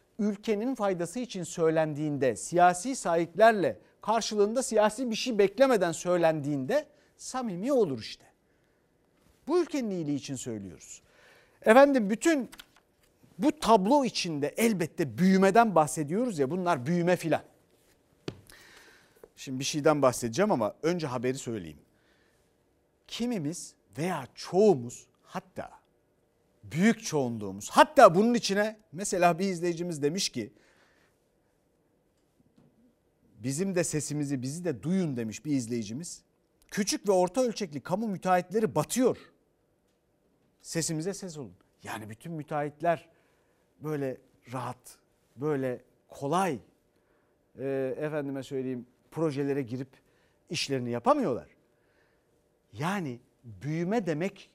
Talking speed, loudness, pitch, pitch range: 100 wpm, -28 LUFS, 165 Hz, 135-205 Hz